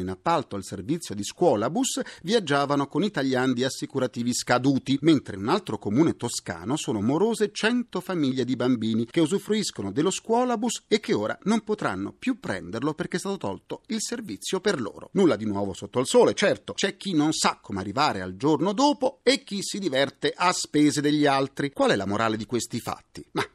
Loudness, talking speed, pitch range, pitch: -25 LUFS, 190 wpm, 125-200 Hz, 150 Hz